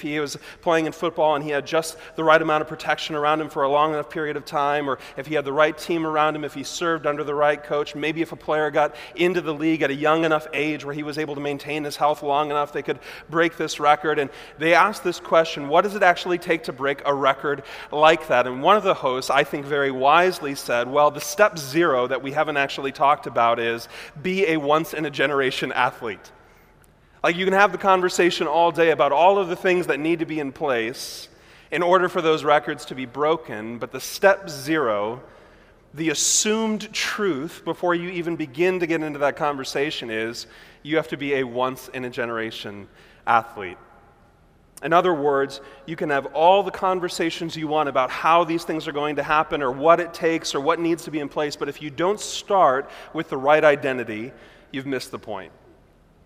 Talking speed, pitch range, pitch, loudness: 220 wpm, 140-165 Hz, 155 Hz, -22 LUFS